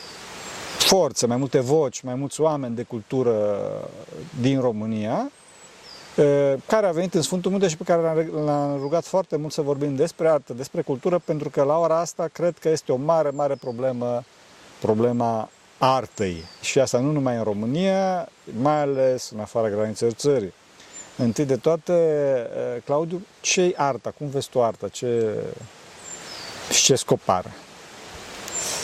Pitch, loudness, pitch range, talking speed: 140 Hz, -23 LUFS, 120-160 Hz, 150 wpm